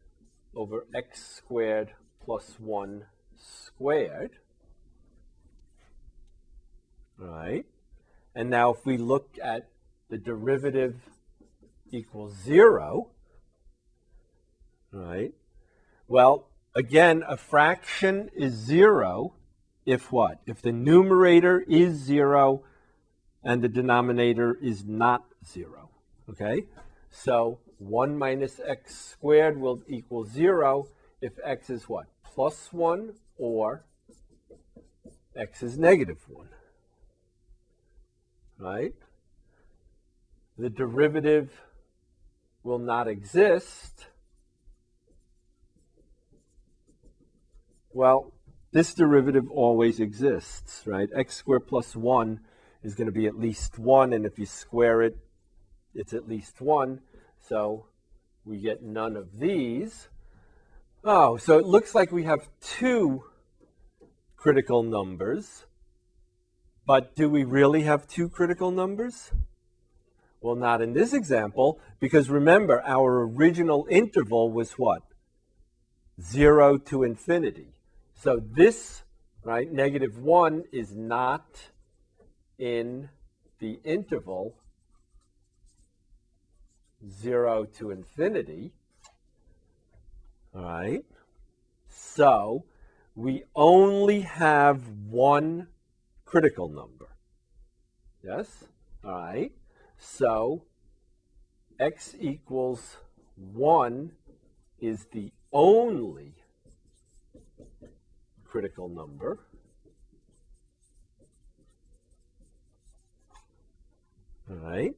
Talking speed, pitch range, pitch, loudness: 85 wpm, 105-145 Hz, 120 Hz, -24 LUFS